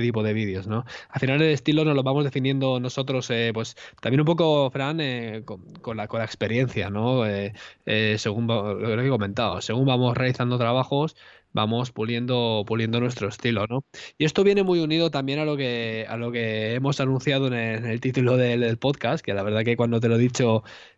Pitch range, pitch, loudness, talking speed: 110-135 Hz, 120 Hz, -24 LUFS, 215 wpm